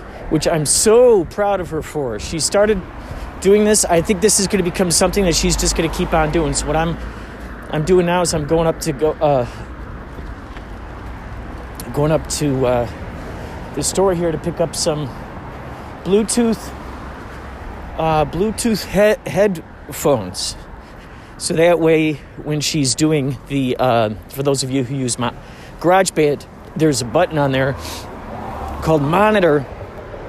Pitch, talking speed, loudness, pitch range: 155 Hz, 155 wpm, -17 LUFS, 125-180 Hz